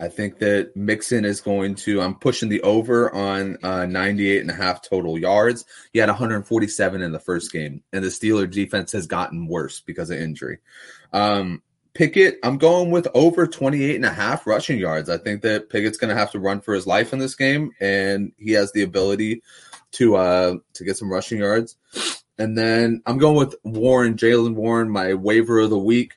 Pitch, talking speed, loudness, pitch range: 105 Hz, 200 wpm, -20 LUFS, 95-115 Hz